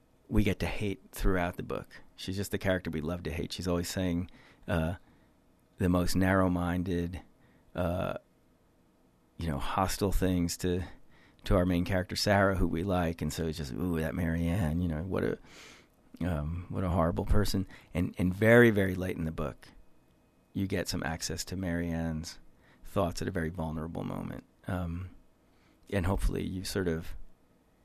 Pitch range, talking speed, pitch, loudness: 85-95 Hz, 170 wpm, 90 Hz, -32 LUFS